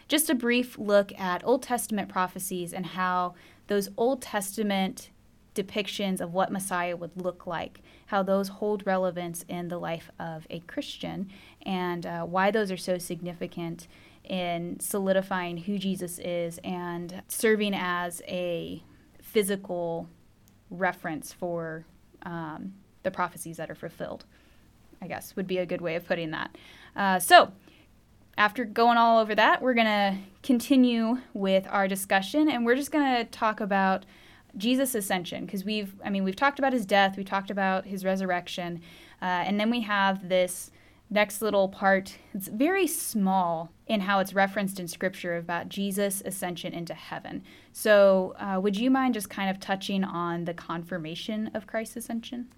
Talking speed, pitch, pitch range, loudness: 160 wpm, 195 Hz, 175-215 Hz, -28 LUFS